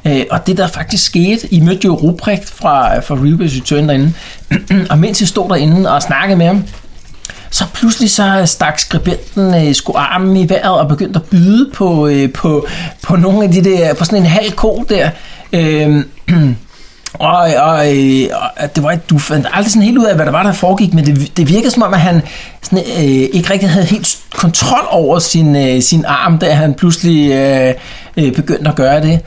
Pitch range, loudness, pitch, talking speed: 145-190 Hz, -11 LUFS, 165 Hz, 185 wpm